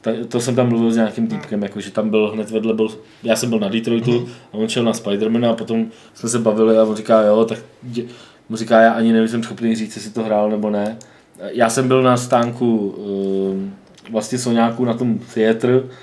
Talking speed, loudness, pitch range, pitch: 215 wpm, -18 LUFS, 110-120 Hz, 115 Hz